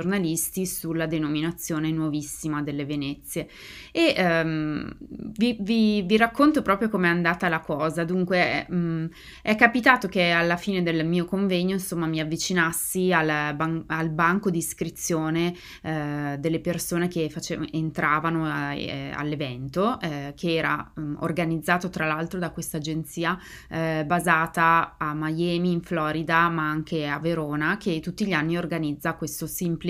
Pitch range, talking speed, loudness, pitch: 155-180 Hz, 145 wpm, -25 LUFS, 165 Hz